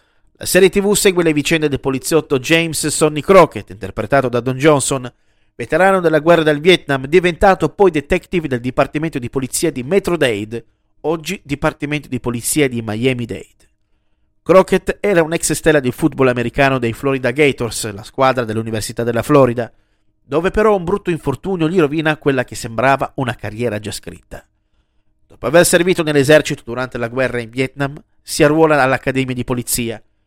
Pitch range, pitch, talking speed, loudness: 120-160 Hz, 140 Hz, 160 wpm, -15 LUFS